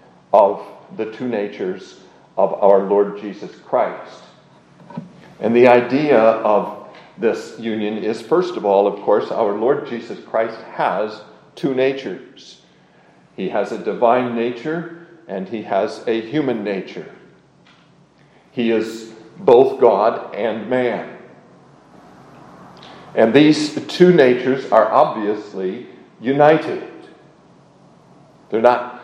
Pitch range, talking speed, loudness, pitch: 105-135 Hz, 110 wpm, -17 LUFS, 120 Hz